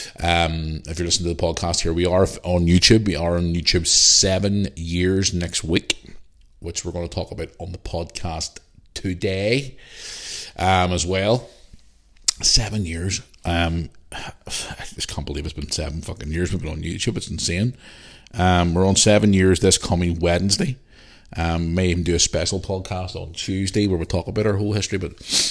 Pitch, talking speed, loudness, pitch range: 90 Hz, 180 wpm, -20 LUFS, 85-95 Hz